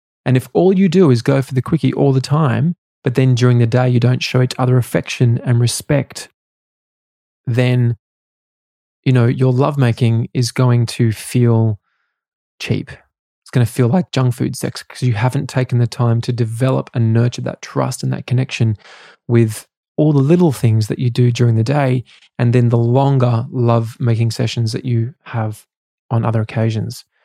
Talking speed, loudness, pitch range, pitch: 180 wpm, -16 LUFS, 115-130 Hz, 125 Hz